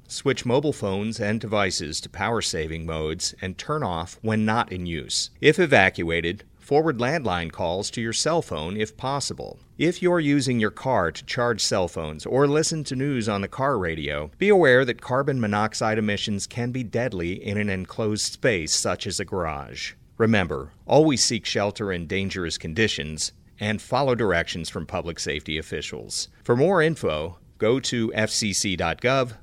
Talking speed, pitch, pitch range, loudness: 165 wpm, 105 Hz, 90-120 Hz, -24 LUFS